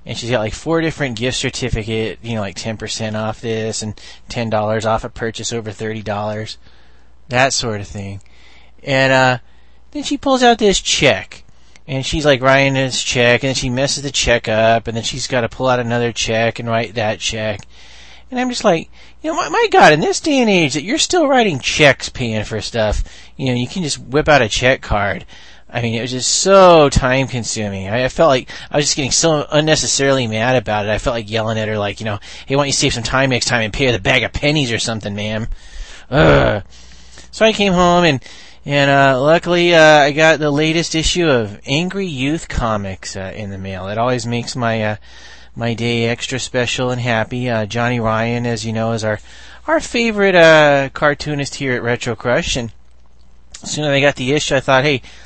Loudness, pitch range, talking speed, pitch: -15 LUFS, 110-145 Hz, 220 wpm, 120 Hz